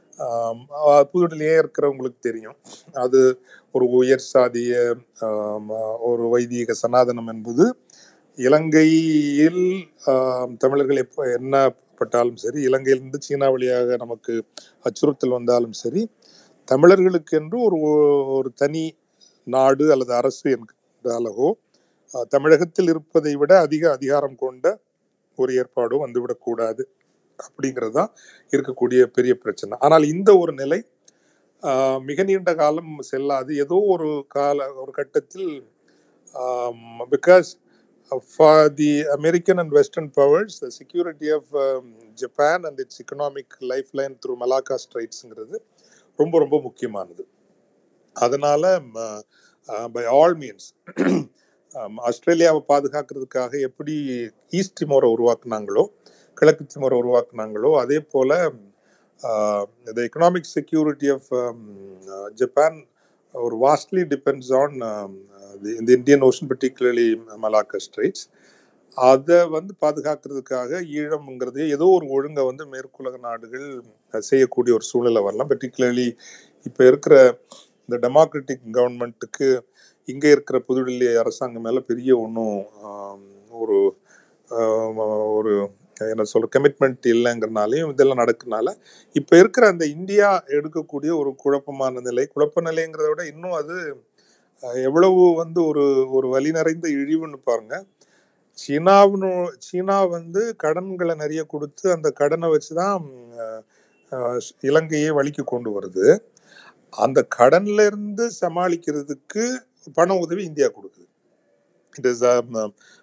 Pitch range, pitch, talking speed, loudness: 125-170 Hz, 140 Hz, 95 wpm, -20 LUFS